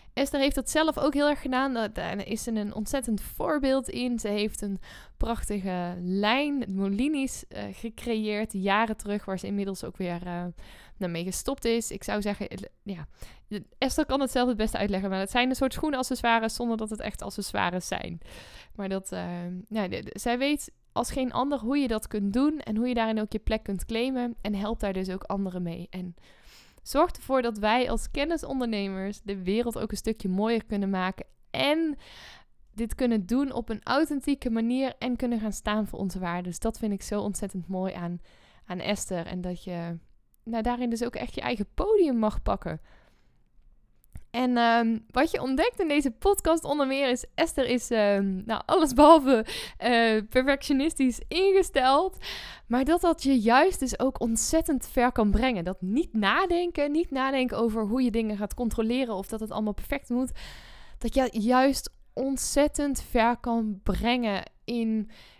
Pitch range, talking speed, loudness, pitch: 205-265 Hz, 180 wpm, -27 LUFS, 230 Hz